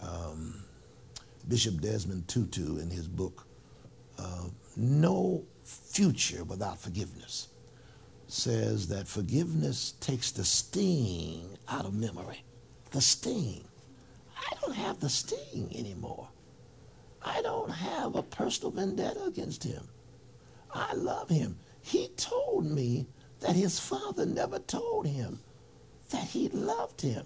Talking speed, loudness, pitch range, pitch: 115 wpm, -32 LUFS, 95-140 Hz, 120 Hz